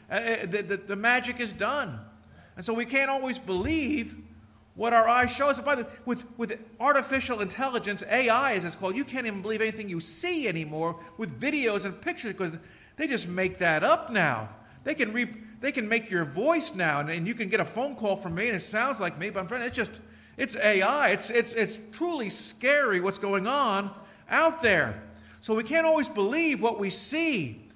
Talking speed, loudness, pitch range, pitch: 205 wpm, -27 LUFS, 190-255 Hz, 220 Hz